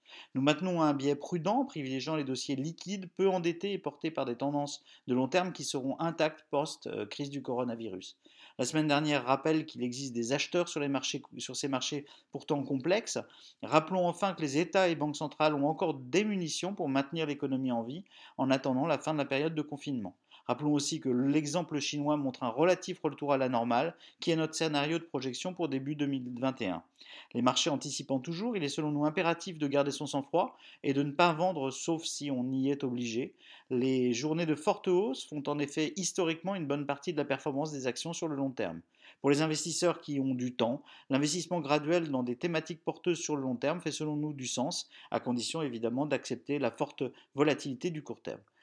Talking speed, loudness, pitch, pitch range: 205 wpm, -33 LUFS, 145 Hz, 135-165 Hz